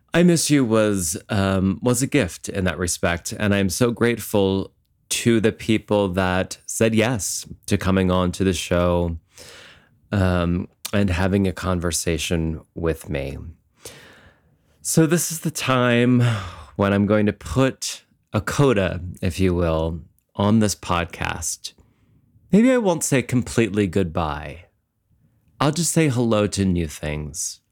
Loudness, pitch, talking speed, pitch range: -21 LUFS, 100 Hz, 140 wpm, 90-120 Hz